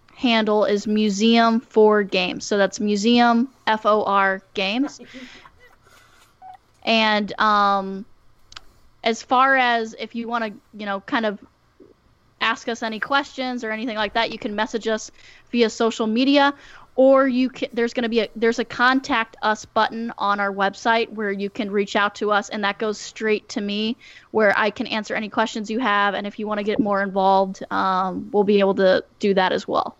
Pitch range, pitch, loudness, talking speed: 205-235 Hz, 220 Hz, -21 LUFS, 180 wpm